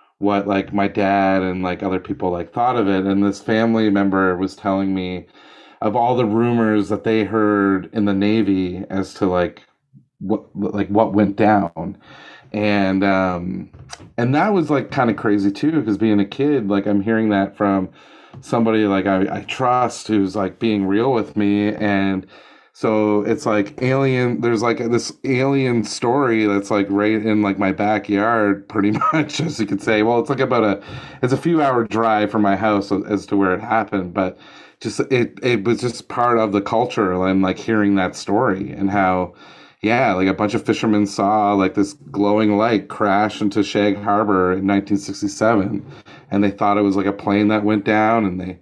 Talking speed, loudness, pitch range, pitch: 190 wpm, -18 LUFS, 100-110 Hz, 105 Hz